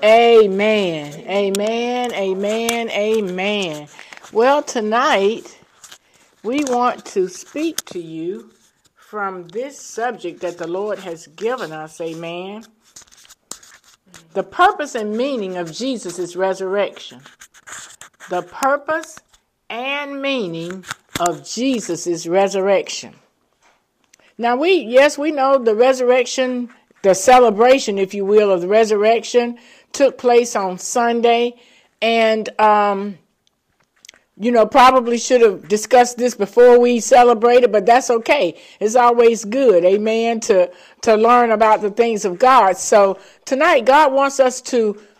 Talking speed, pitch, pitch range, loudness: 115 wpm, 225 Hz, 195-250 Hz, -16 LUFS